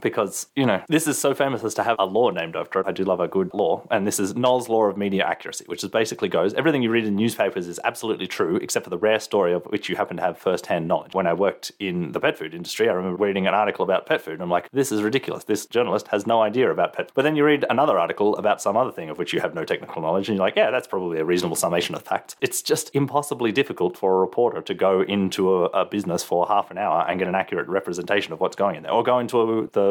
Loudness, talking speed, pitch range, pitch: -23 LUFS, 285 wpm, 95-125 Hz, 110 Hz